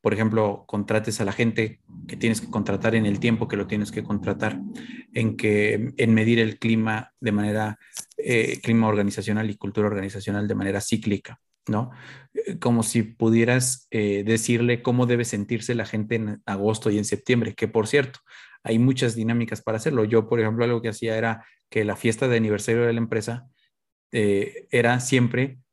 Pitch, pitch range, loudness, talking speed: 110 Hz, 105-120 Hz, -24 LUFS, 180 wpm